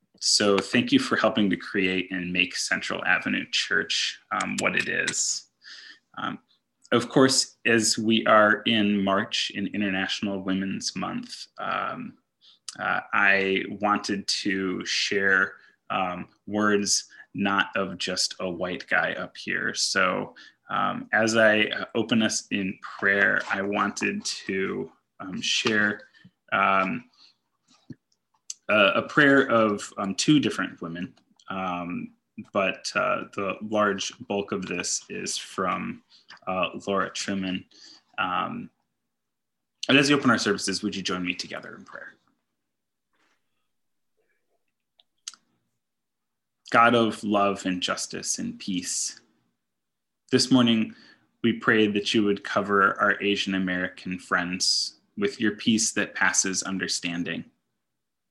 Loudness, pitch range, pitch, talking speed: -24 LUFS, 90-110 Hz, 100 Hz, 120 wpm